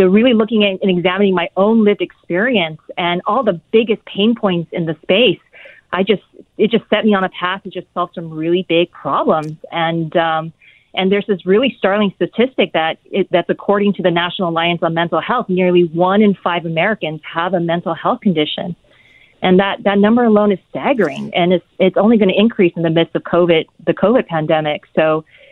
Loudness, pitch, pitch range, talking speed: -15 LUFS, 185 Hz, 170-205 Hz, 205 wpm